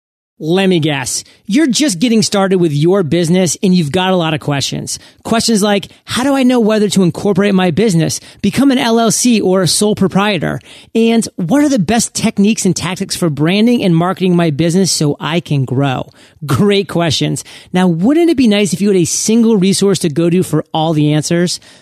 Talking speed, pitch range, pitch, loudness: 200 wpm, 170-215 Hz, 190 Hz, -12 LUFS